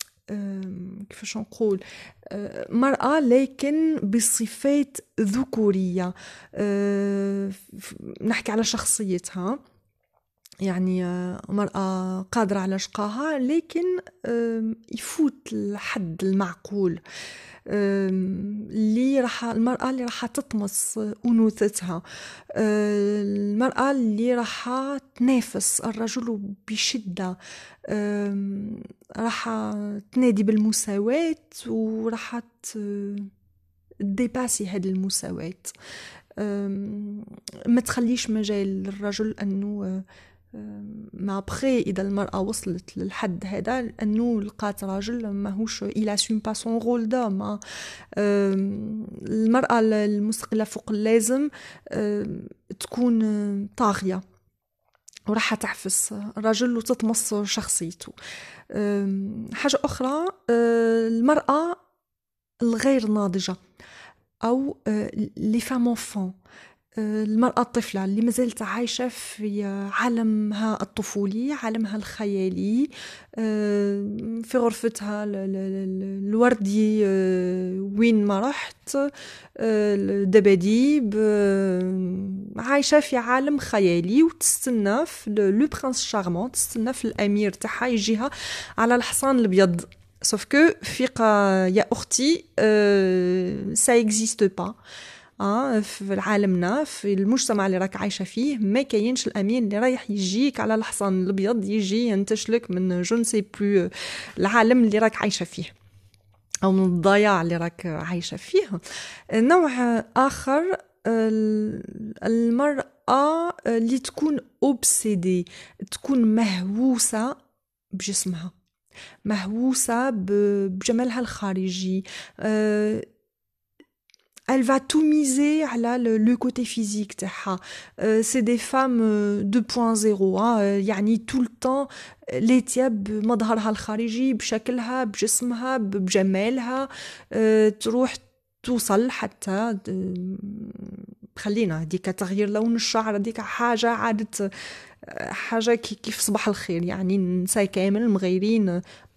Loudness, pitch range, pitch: -24 LUFS, 200-240 Hz, 215 Hz